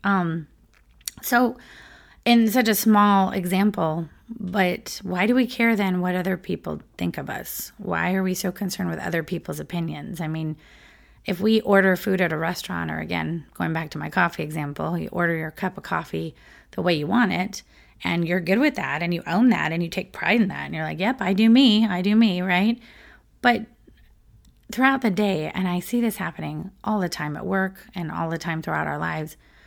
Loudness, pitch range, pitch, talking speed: -23 LUFS, 165-215 Hz, 185 Hz, 210 wpm